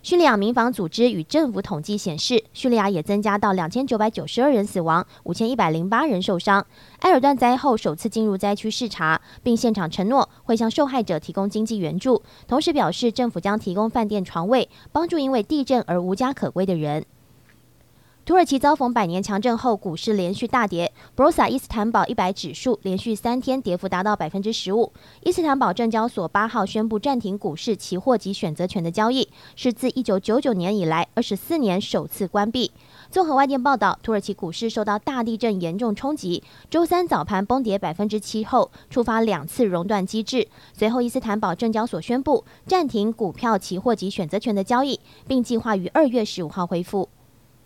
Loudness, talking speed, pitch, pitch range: -22 LUFS, 315 characters per minute, 215 Hz, 190-250 Hz